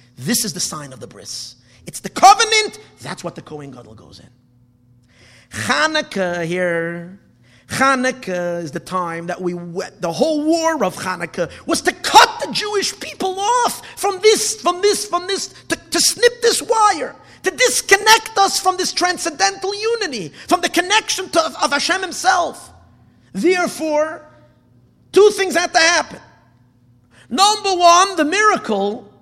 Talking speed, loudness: 150 wpm, -16 LUFS